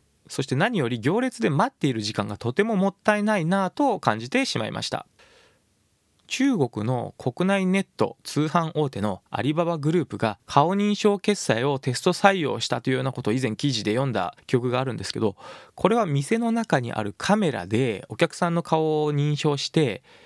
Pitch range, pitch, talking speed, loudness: 125-195 Hz, 150 Hz, 380 characters per minute, -24 LUFS